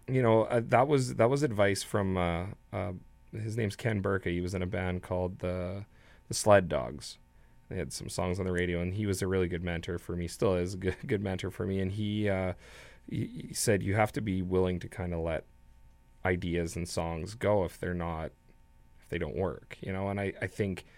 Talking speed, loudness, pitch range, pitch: 225 wpm, -32 LUFS, 85-105 Hz, 95 Hz